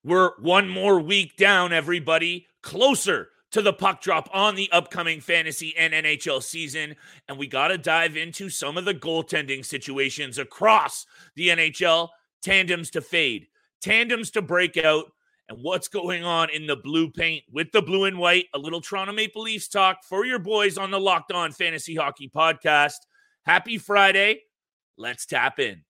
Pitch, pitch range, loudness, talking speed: 175 Hz, 160-195 Hz, -22 LUFS, 170 wpm